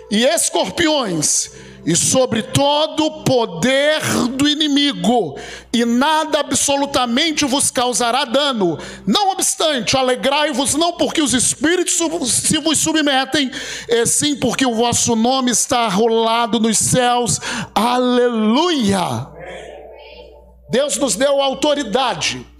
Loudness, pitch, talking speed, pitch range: -16 LUFS, 265 Hz, 105 wpm, 235-295 Hz